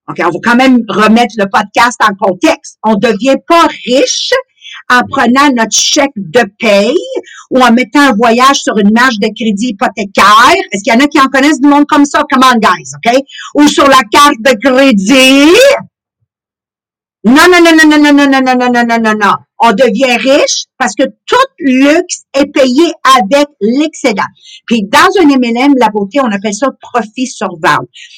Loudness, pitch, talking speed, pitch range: -7 LUFS, 260 Hz, 185 wpm, 225-285 Hz